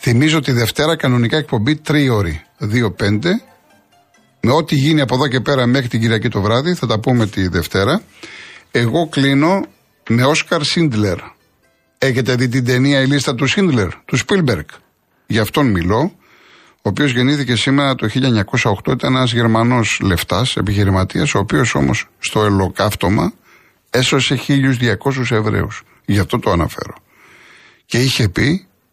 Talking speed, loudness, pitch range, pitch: 145 wpm, -16 LUFS, 110-140 Hz, 125 Hz